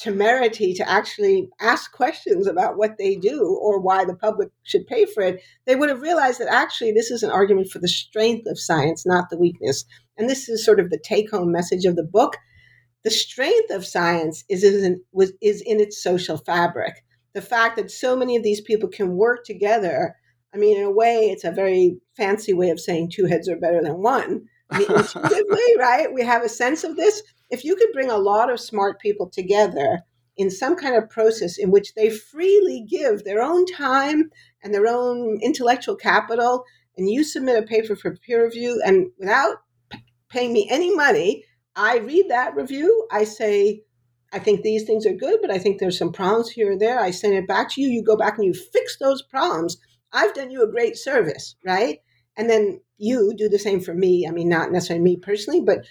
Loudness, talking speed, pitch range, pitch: -20 LUFS, 215 wpm, 185-275 Hz, 215 Hz